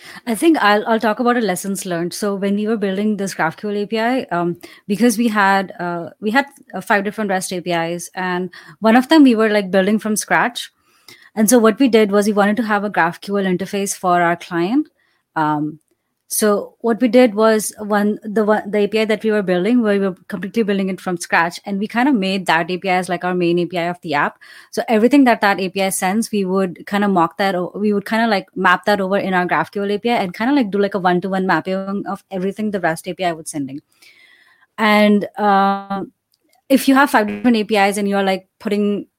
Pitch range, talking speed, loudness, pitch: 185-220 Hz, 225 wpm, -17 LUFS, 200 Hz